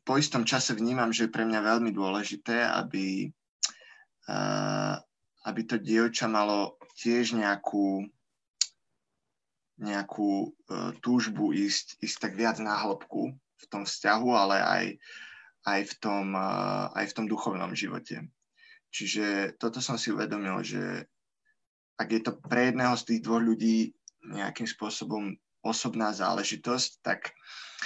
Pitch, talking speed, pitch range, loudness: 110 Hz, 125 wpm, 105-120 Hz, -30 LUFS